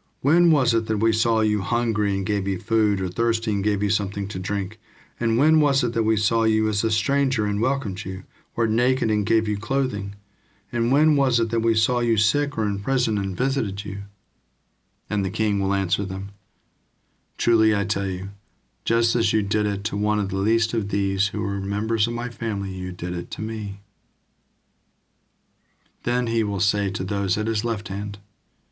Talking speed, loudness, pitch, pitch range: 205 wpm, -23 LUFS, 105 Hz, 100-115 Hz